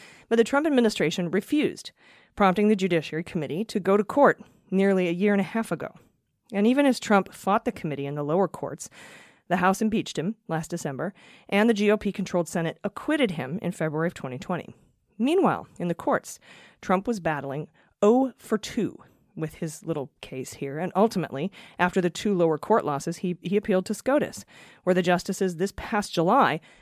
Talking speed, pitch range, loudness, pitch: 185 wpm, 165-215 Hz, -25 LUFS, 190 Hz